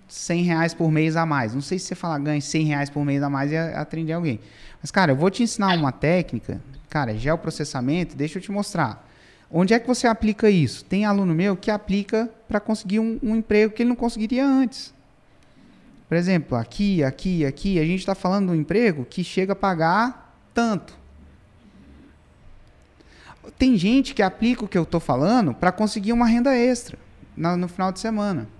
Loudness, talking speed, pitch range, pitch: -22 LUFS, 190 wpm, 145-215 Hz, 180 Hz